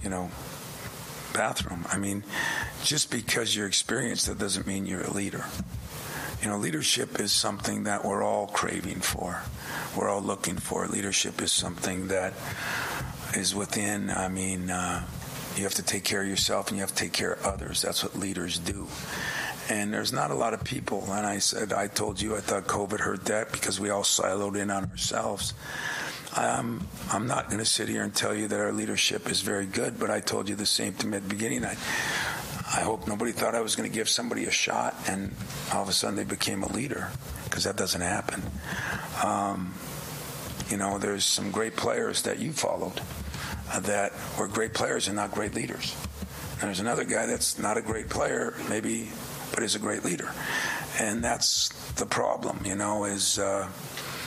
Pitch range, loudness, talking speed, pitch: 95-105 Hz, -29 LUFS, 195 wpm, 100 Hz